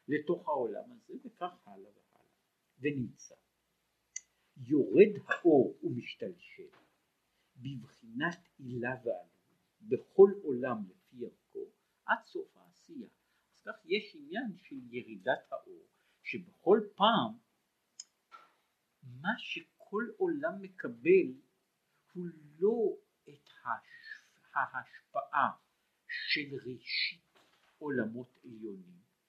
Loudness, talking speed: -33 LUFS, 85 wpm